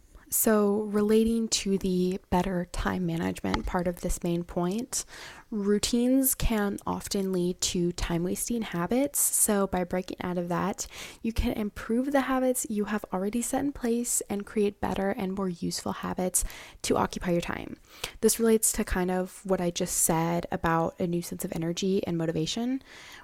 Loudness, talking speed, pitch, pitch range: -28 LUFS, 170 wpm, 195 Hz, 180-220 Hz